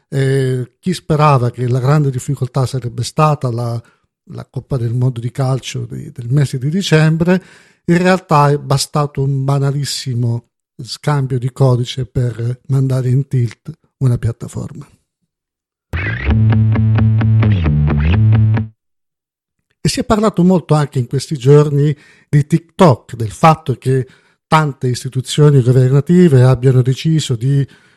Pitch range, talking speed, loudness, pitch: 125-150 Hz, 120 wpm, -14 LUFS, 135 Hz